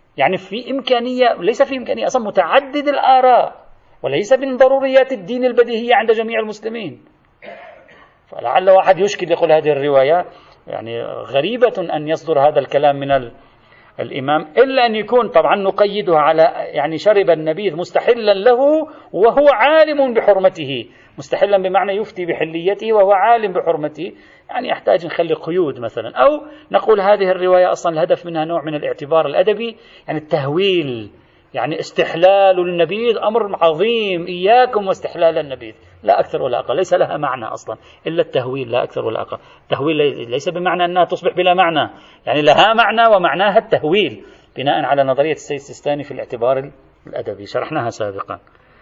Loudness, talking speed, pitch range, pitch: -15 LUFS, 140 wpm, 160-245 Hz, 195 Hz